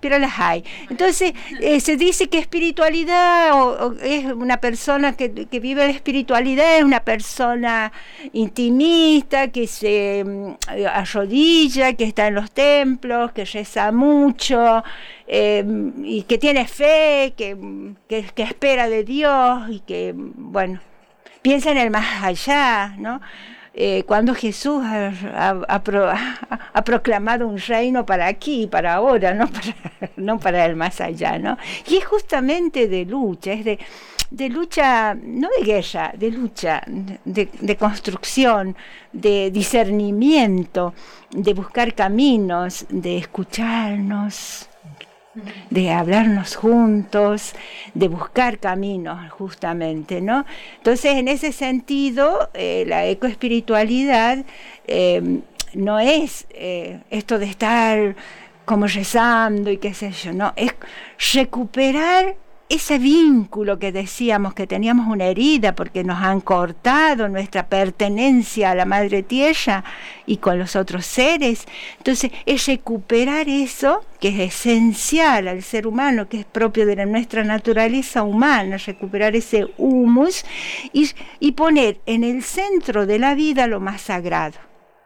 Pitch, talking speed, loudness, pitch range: 225 Hz, 130 wpm, -18 LUFS, 200-270 Hz